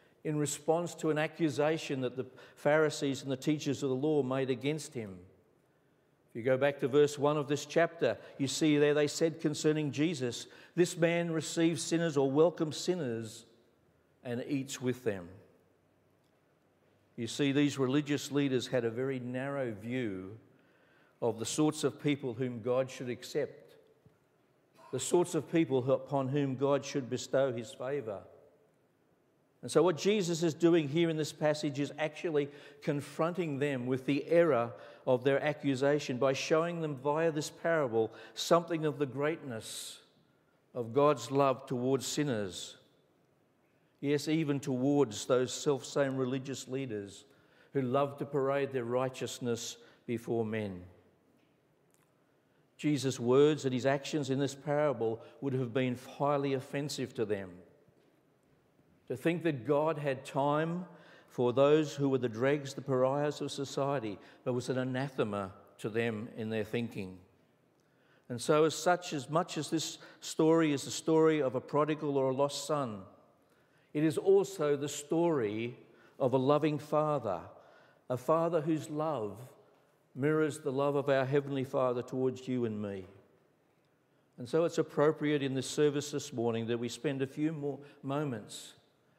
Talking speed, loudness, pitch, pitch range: 150 wpm, -33 LUFS, 140 Hz, 130-155 Hz